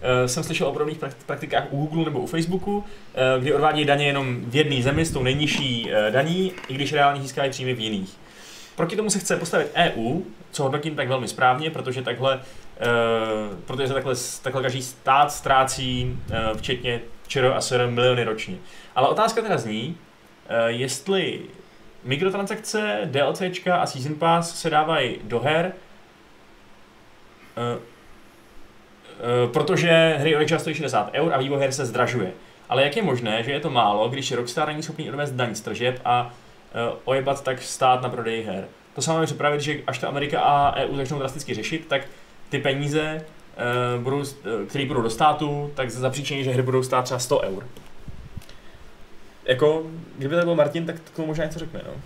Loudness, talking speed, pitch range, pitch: -23 LUFS, 175 wpm, 125-160 Hz, 140 Hz